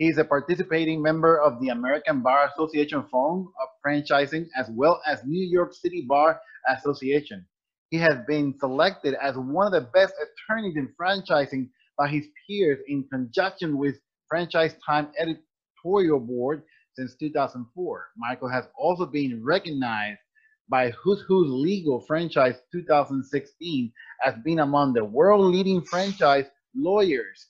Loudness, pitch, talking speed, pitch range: -24 LUFS, 150 Hz, 140 wpm, 140-180 Hz